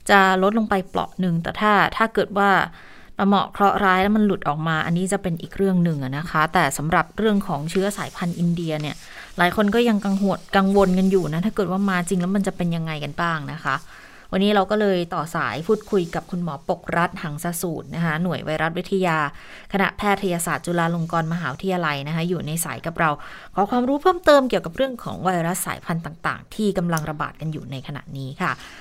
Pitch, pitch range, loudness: 180 Hz, 160-195 Hz, -22 LUFS